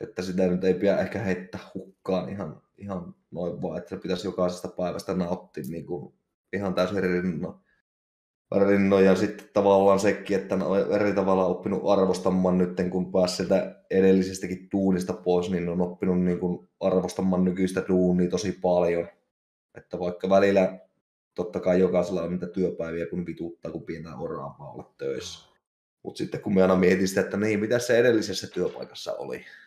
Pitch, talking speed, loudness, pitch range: 95 Hz, 170 wpm, -25 LUFS, 90-95 Hz